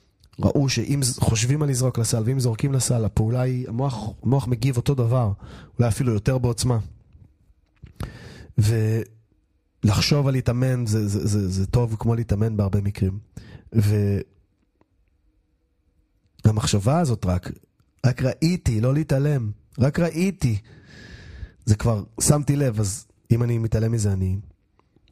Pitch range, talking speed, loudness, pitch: 100-130 Hz, 120 wpm, -23 LUFS, 115 Hz